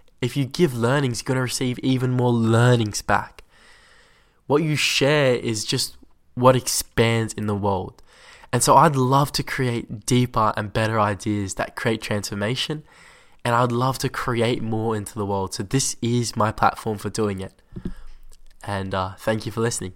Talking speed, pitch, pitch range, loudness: 175 wpm, 115 Hz, 105-130 Hz, -22 LUFS